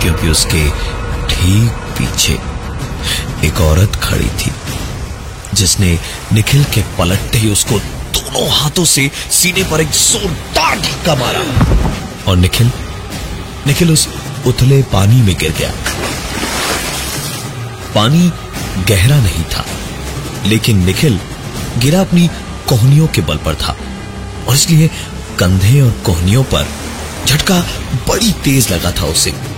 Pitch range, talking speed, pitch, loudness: 90-135 Hz, 115 wpm, 105 Hz, -13 LUFS